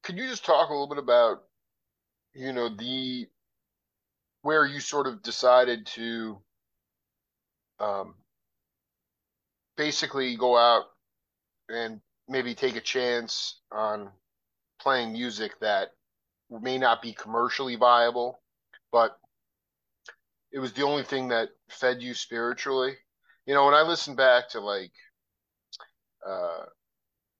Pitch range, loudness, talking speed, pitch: 115-135 Hz, -26 LUFS, 120 wpm, 125 Hz